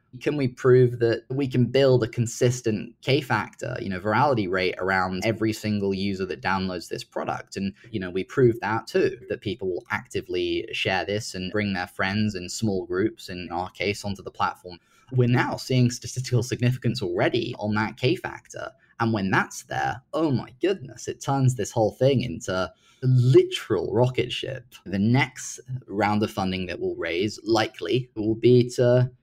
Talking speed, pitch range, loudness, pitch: 180 wpm, 100-125 Hz, -25 LUFS, 115 Hz